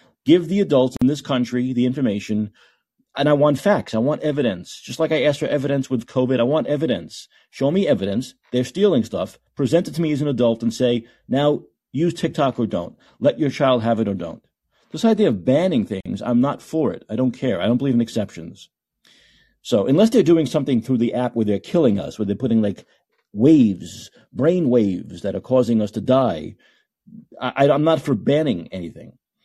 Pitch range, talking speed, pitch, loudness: 115-150 Hz, 205 wpm, 130 Hz, -20 LUFS